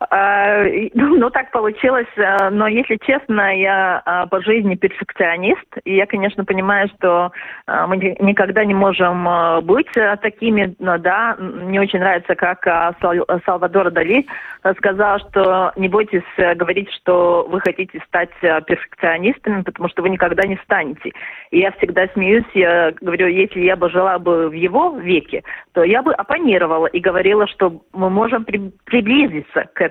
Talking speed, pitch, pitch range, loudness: 140 wpm, 190 Hz, 180-205 Hz, -16 LUFS